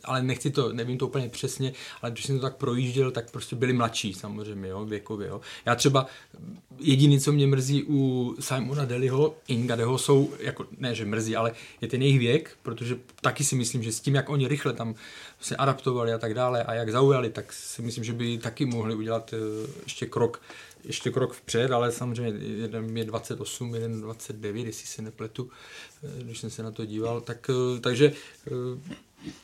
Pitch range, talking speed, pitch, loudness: 115-135 Hz, 185 wpm, 125 Hz, -28 LUFS